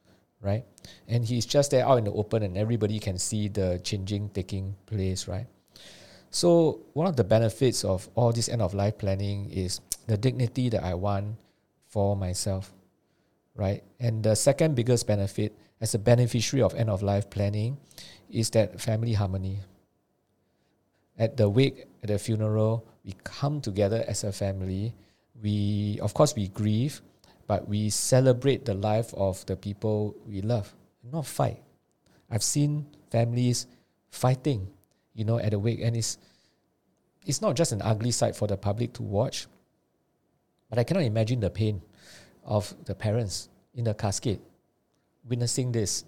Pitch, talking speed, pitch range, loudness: 105 Hz, 160 wpm, 100-120 Hz, -28 LUFS